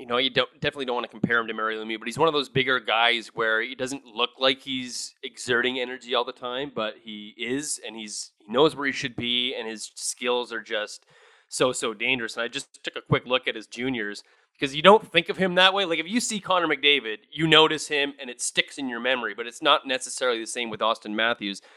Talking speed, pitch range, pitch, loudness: 255 wpm, 115-145 Hz, 125 Hz, -24 LUFS